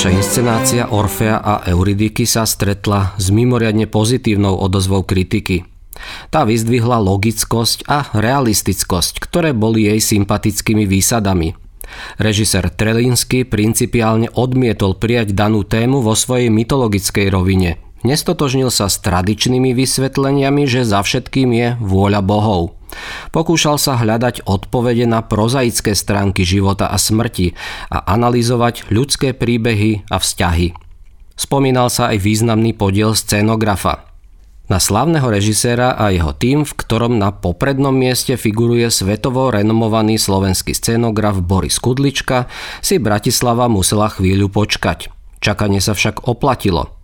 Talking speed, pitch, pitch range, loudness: 120 wpm, 110 Hz, 100-120 Hz, -14 LUFS